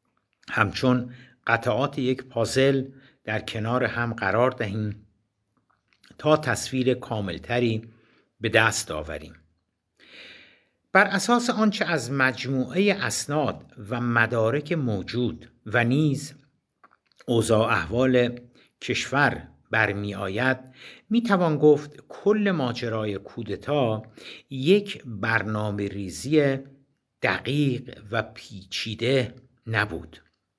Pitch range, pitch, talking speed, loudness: 110-135 Hz, 120 Hz, 85 wpm, -25 LUFS